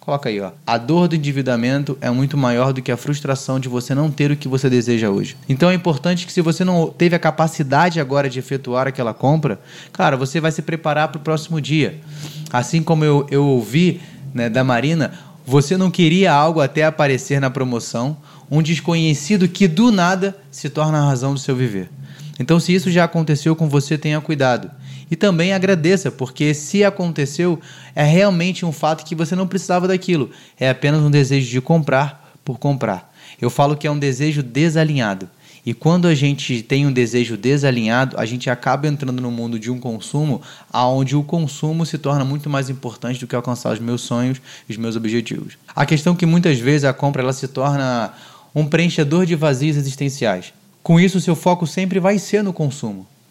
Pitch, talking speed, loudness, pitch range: 145 Hz, 195 wpm, -18 LUFS, 130-165 Hz